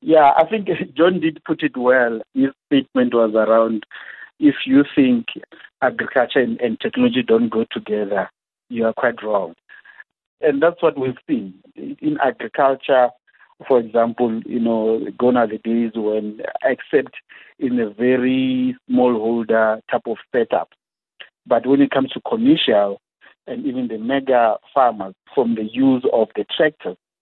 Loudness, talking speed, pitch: -18 LUFS, 145 wpm, 130 Hz